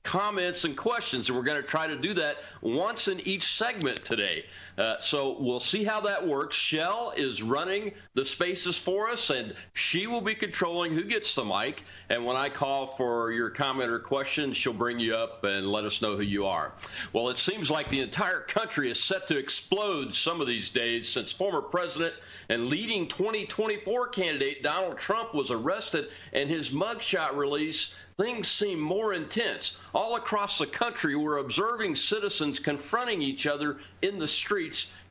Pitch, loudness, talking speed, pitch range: 150 Hz, -29 LUFS, 180 wpm, 130-195 Hz